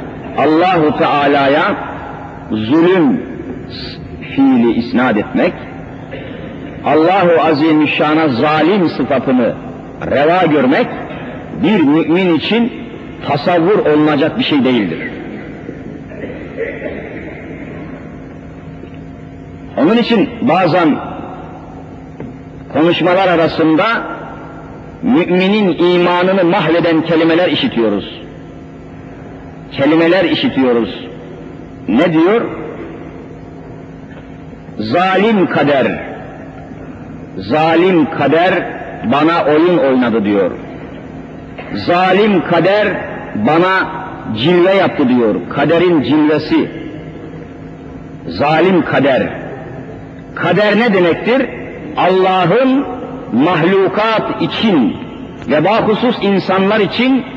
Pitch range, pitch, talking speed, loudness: 155-210 Hz, 175 Hz, 65 wpm, -12 LUFS